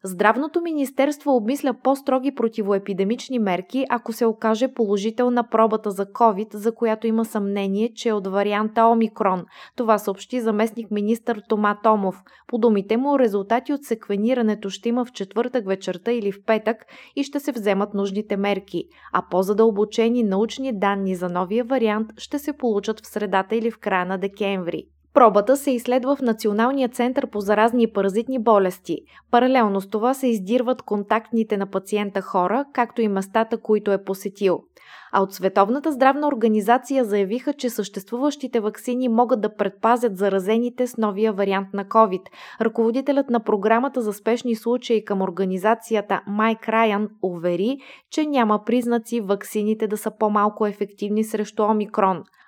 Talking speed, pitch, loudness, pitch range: 150 wpm, 220 Hz, -22 LUFS, 205-240 Hz